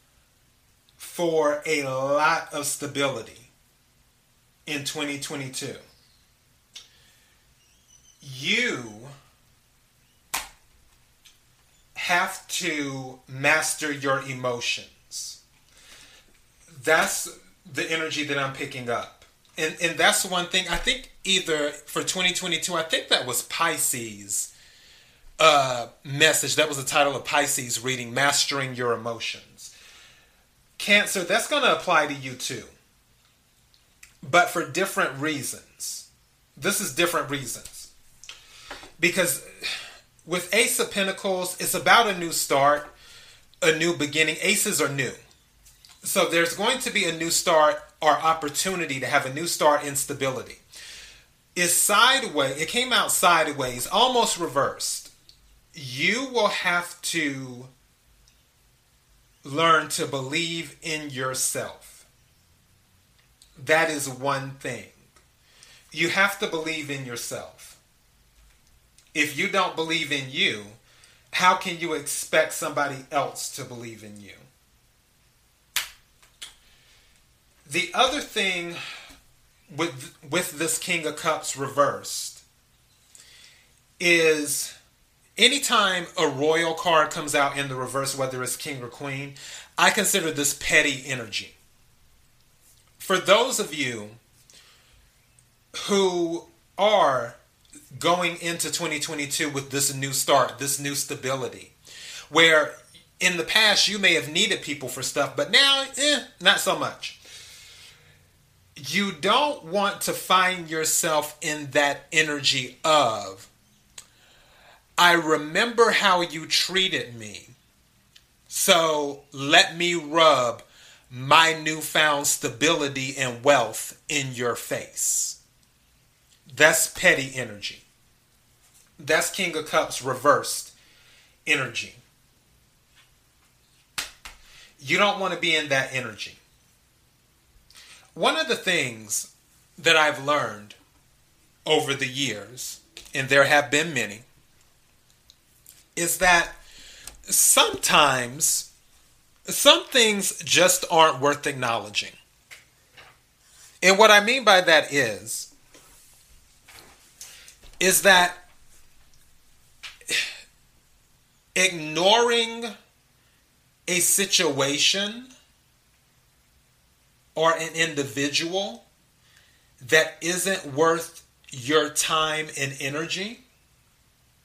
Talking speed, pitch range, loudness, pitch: 100 wpm, 130-170 Hz, -22 LUFS, 150 Hz